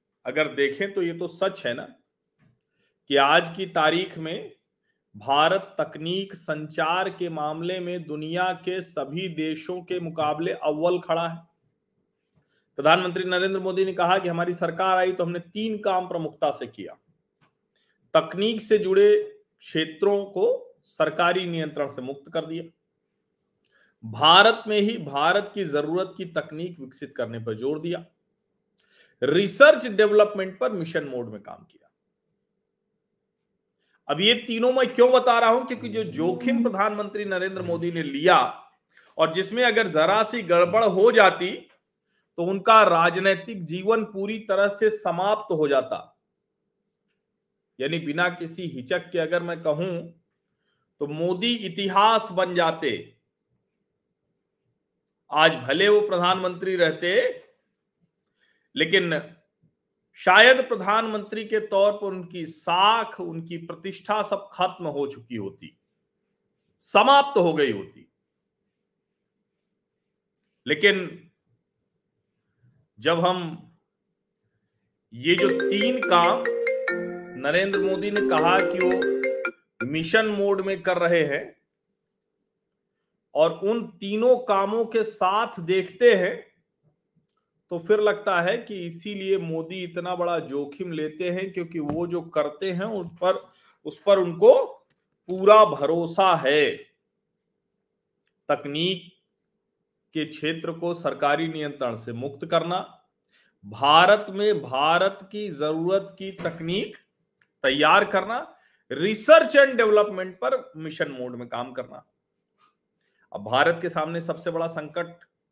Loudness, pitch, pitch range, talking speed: -23 LUFS, 185 Hz, 165-210 Hz, 125 wpm